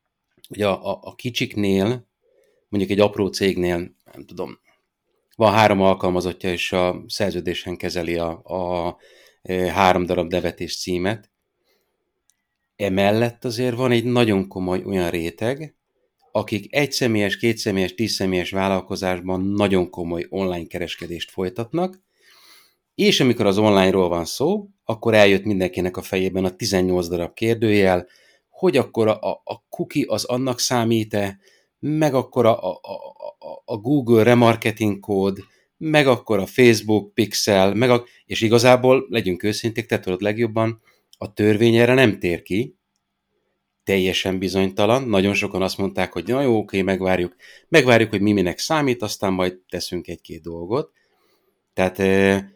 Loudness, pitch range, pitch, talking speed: -20 LUFS, 90-120 Hz, 100 Hz, 135 wpm